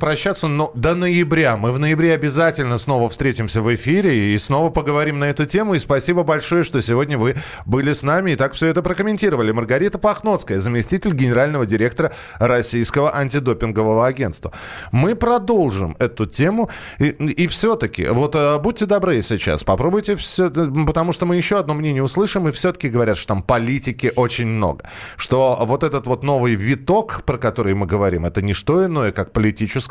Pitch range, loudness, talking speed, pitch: 115-165 Hz, -18 LUFS, 170 wpm, 140 Hz